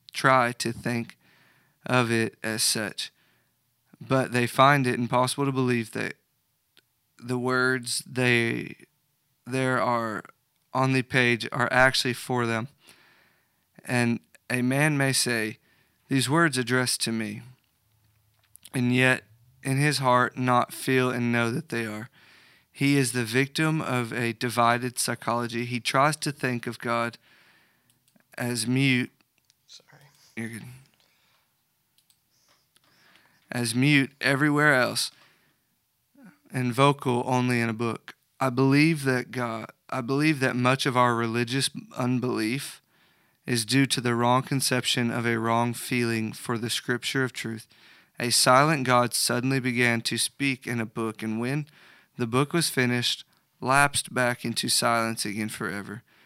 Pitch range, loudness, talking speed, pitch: 115-130 Hz, -25 LUFS, 130 wpm, 125 Hz